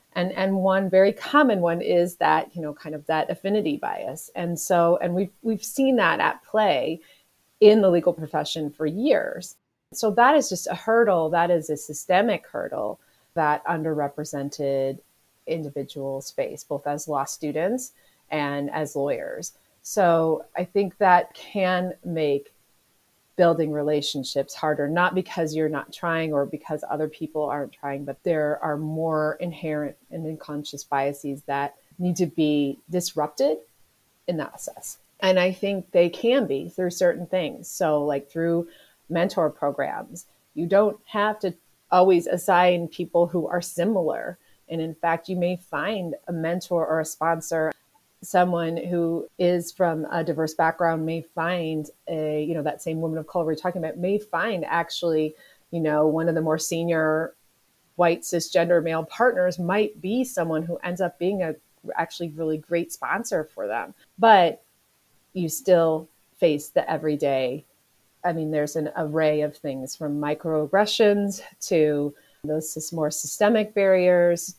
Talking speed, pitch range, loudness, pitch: 155 wpm, 150-180 Hz, -24 LUFS, 165 Hz